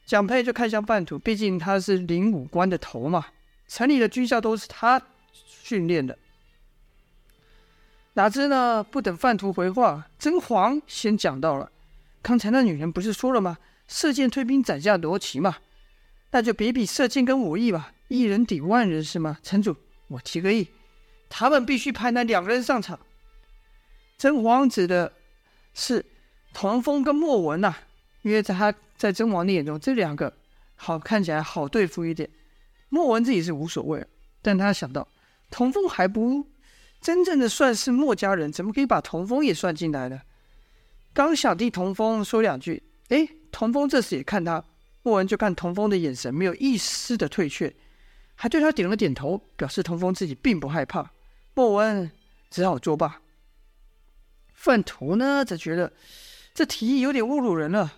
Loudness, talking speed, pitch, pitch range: -24 LUFS, 245 characters per minute, 210 Hz, 170-250 Hz